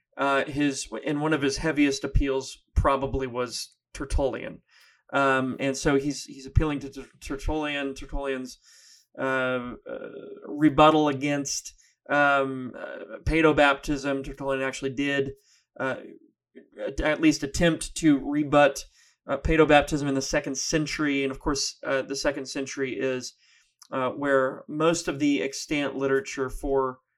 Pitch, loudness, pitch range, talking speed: 140 Hz, -26 LUFS, 135-150 Hz, 130 wpm